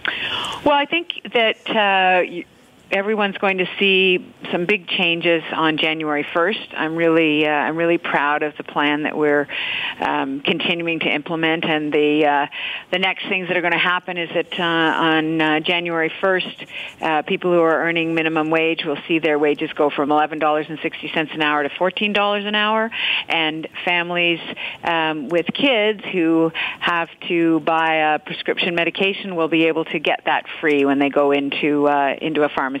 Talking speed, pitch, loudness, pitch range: 175 wpm, 165 Hz, -19 LUFS, 155-180 Hz